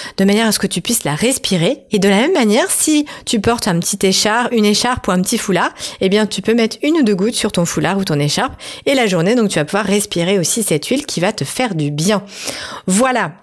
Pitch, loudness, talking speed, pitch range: 210 Hz, -15 LUFS, 265 wpm, 190-235 Hz